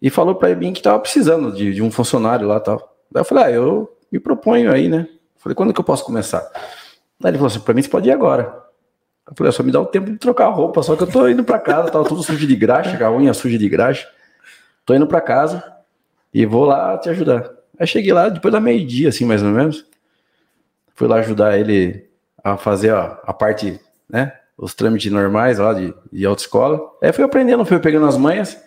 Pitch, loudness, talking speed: 130 Hz, -16 LUFS, 230 wpm